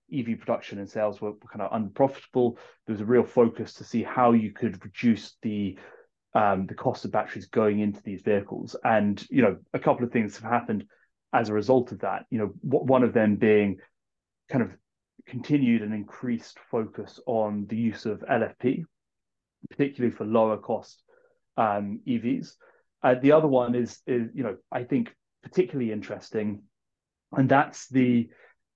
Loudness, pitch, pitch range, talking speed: -26 LUFS, 115 Hz, 105-130 Hz, 170 wpm